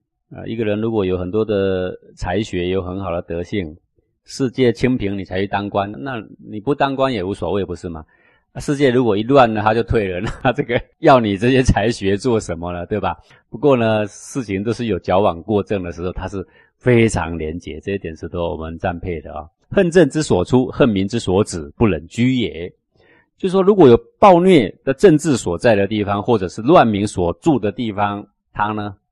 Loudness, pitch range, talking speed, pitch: -17 LUFS, 90-120 Hz, 295 characters per minute, 105 Hz